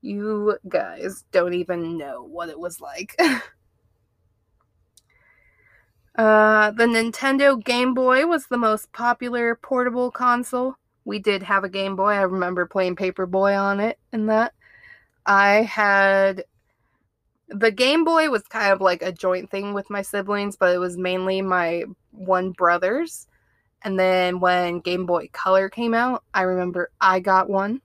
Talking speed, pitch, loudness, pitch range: 150 wpm, 195 Hz, -21 LUFS, 180-225 Hz